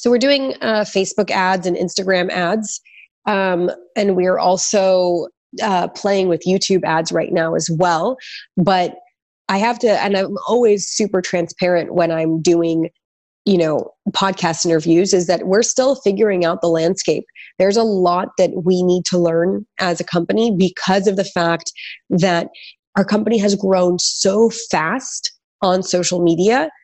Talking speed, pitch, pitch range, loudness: 160 wpm, 185 Hz, 175-210 Hz, -17 LUFS